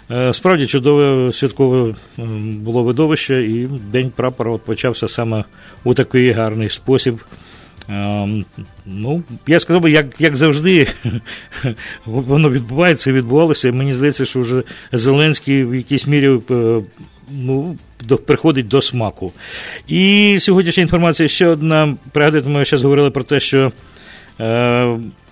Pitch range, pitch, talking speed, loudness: 115-145 Hz, 130 Hz, 125 wpm, -15 LUFS